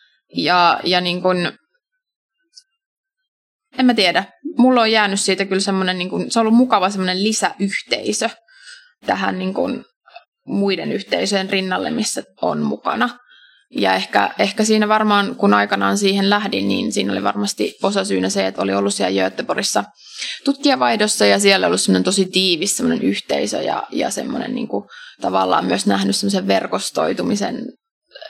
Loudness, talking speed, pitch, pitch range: -18 LUFS, 140 wpm, 195 Hz, 175-245 Hz